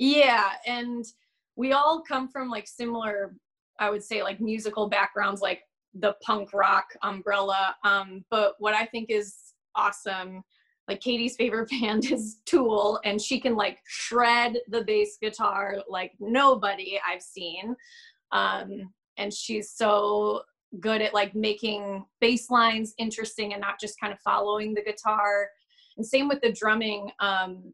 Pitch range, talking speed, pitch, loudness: 200-235 Hz, 150 wpm, 215 Hz, -26 LUFS